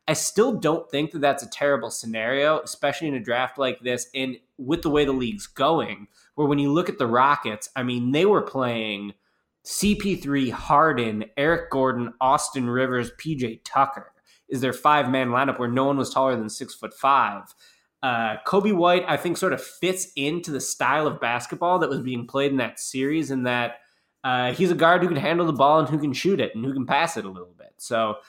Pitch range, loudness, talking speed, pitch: 125-155 Hz, -23 LUFS, 215 wpm, 135 Hz